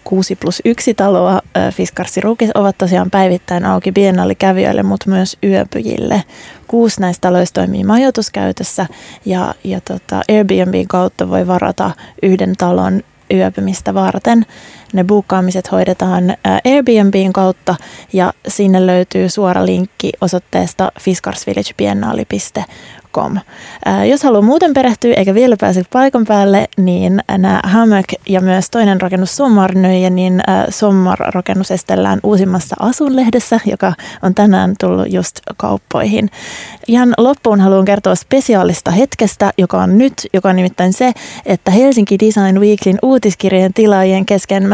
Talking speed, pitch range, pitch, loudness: 125 wpm, 185-215 Hz, 195 Hz, -12 LUFS